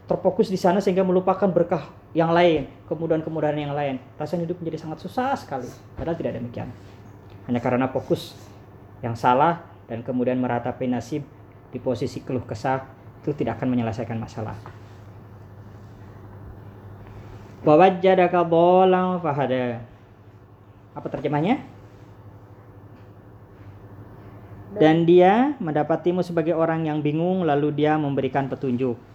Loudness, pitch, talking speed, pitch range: -22 LUFS, 130 Hz, 115 wpm, 105-165 Hz